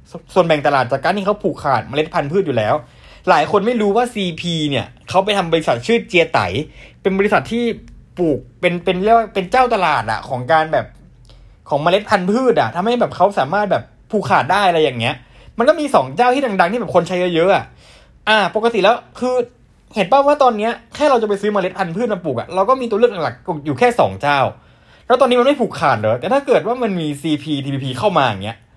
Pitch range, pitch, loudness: 150-230 Hz, 190 Hz, -16 LUFS